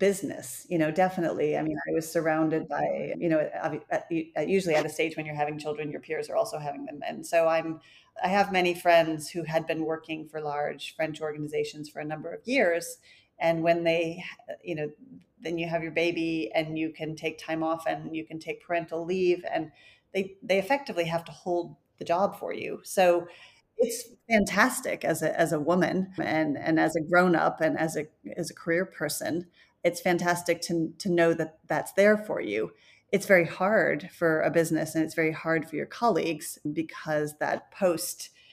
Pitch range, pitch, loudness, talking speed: 160-180 Hz, 165 Hz, -28 LUFS, 195 wpm